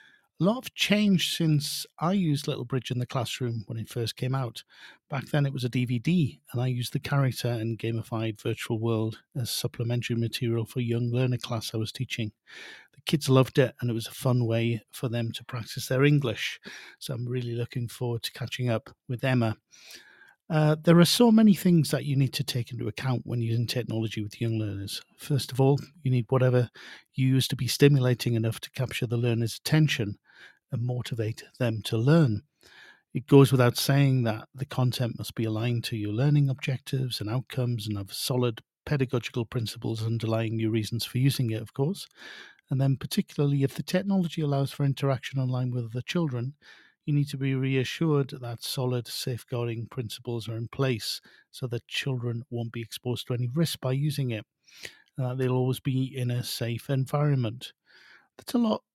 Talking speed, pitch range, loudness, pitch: 190 wpm, 115-140 Hz, -28 LUFS, 125 Hz